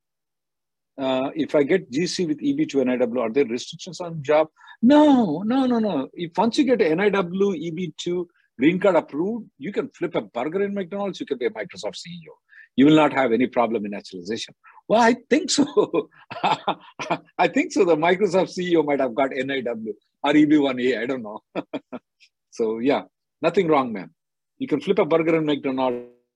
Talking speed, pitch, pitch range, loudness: 180 wpm, 175 Hz, 145-230 Hz, -22 LUFS